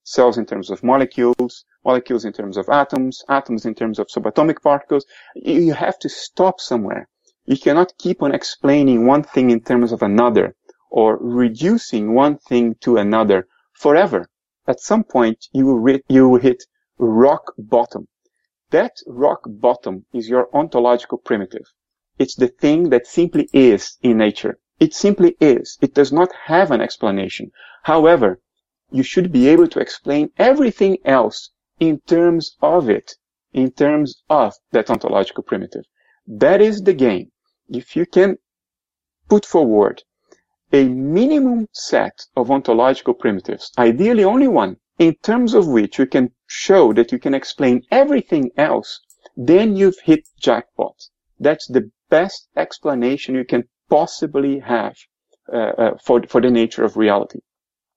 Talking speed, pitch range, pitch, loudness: 150 wpm, 120-190 Hz, 140 Hz, -16 LUFS